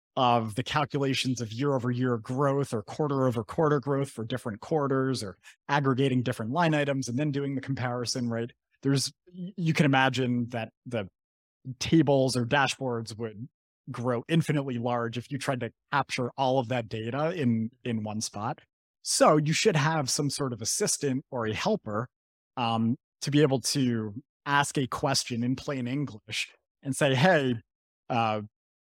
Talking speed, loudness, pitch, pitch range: 165 wpm, -28 LUFS, 130 Hz, 115-145 Hz